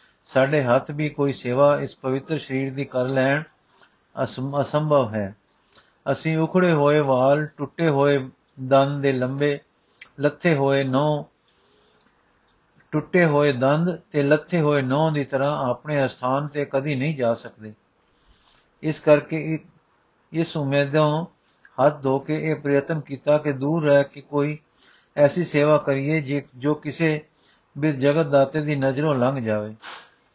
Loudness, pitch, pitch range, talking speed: -22 LUFS, 145 Hz, 135-155 Hz, 135 wpm